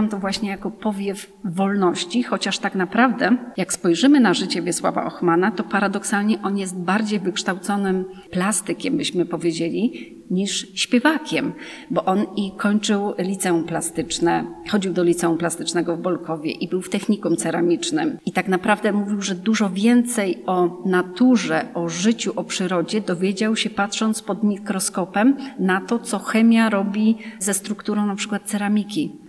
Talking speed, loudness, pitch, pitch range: 145 wpm, -21 LUFS, 200 Hz, 185-215 Hz